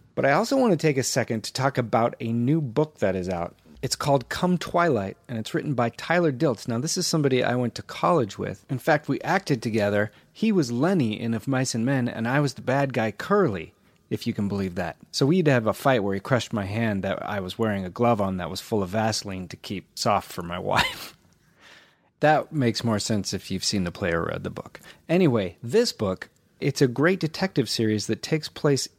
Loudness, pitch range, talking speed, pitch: -25 LUFS, 105-150 Hz, 230 wpm, 120 Hz